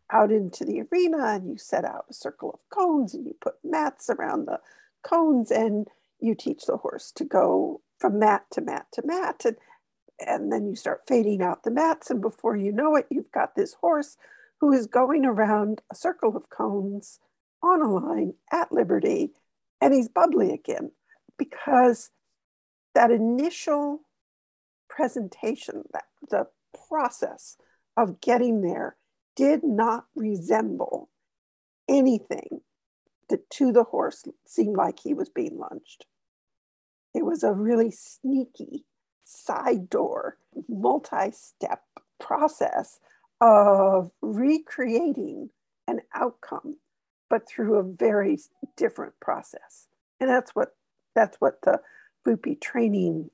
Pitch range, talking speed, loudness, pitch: 225-330 Hz, 135 wpm, -25 LUFS, 275 Hz